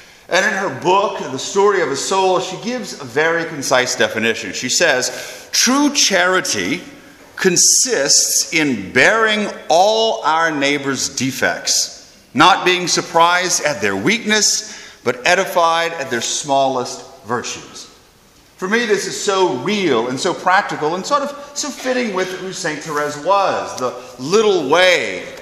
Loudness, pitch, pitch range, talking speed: -16 LUFS, 185 Hz, 150-215 Hz, 140 wpm